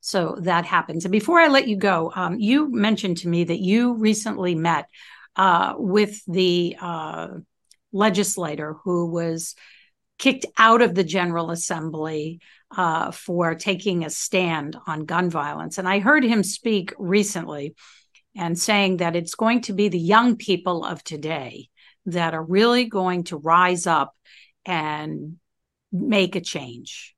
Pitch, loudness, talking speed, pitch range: 180 Hz, -21 LUFS, 150 wpm, 165-205 Hz